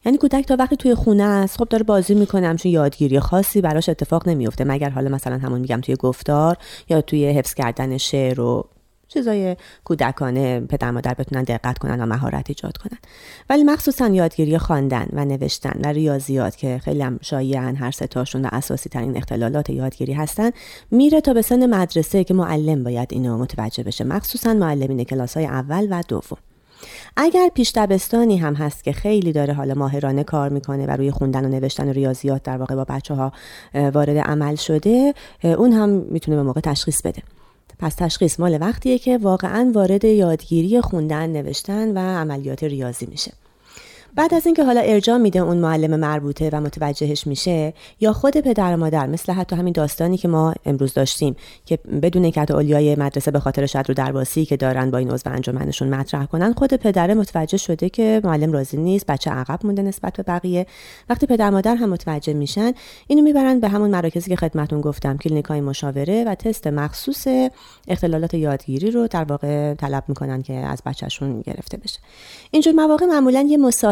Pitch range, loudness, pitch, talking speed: 140-205 Hz, -19 LUFS, 155 Hz, 180 wpm